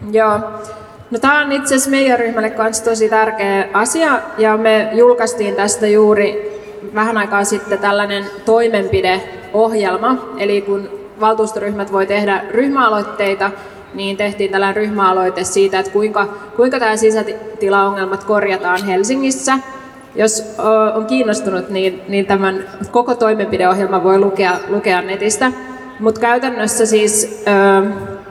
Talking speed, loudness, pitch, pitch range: 115 wpm, -14 LUFS, 210 Hz, 200-220 Hz